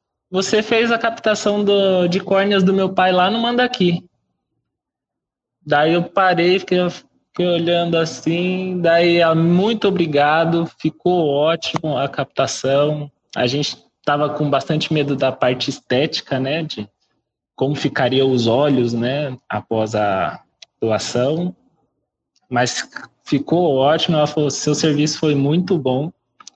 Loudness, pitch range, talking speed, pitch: -18 LUFS, 145-180 Hz, 125 wpm, 160 Hz